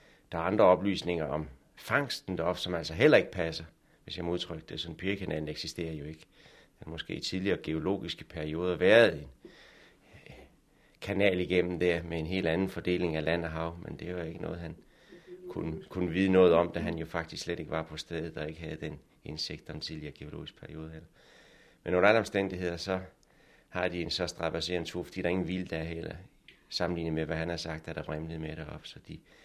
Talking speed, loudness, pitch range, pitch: 210 wpm, -31 LUFS, 80-90 Hz, 85 Hz